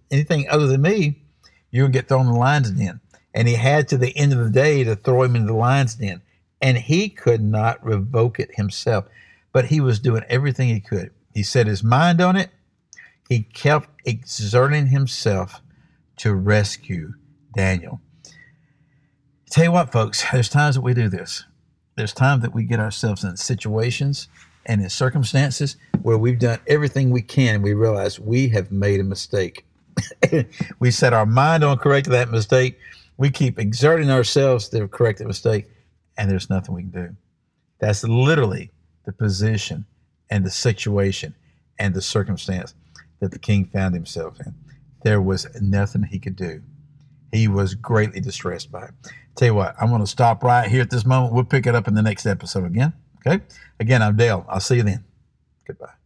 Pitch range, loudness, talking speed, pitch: 105-135 Hz, -20 LUFS, 180 wpm, 120 Hz